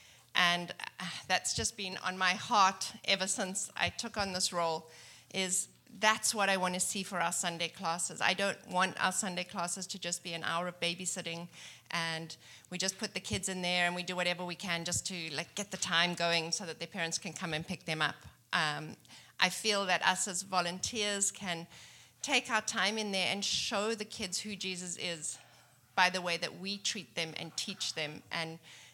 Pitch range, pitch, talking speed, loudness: 170-195 Hz, 180 Hz, 205 wpm, -33 LUFS